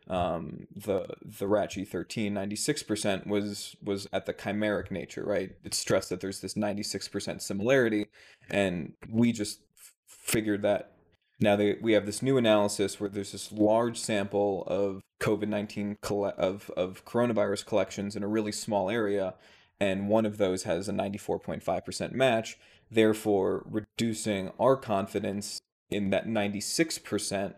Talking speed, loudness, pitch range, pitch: 145 wpm, -30 LUFS, 100-110 Hz, 105 Hz